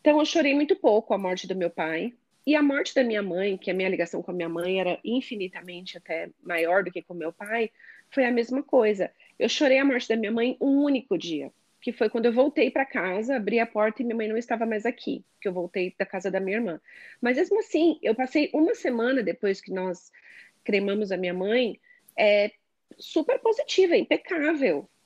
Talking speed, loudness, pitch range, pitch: 220 wpm, -26 LUFS, 185-270 Hz, 225 Hz